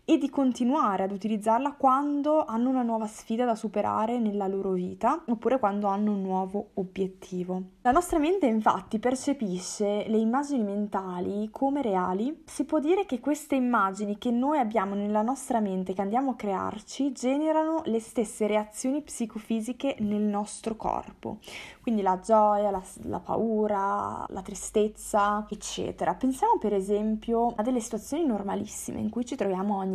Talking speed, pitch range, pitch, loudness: 150 wpm, 205-260 Hz, 220 Hz, -28 LUFS